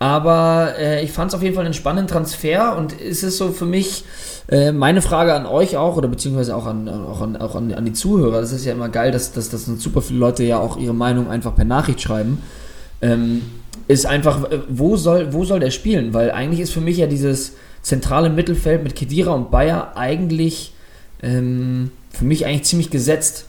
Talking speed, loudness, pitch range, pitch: 210 wpm, -18 LUFS, 125-165 Hz, 145 Hz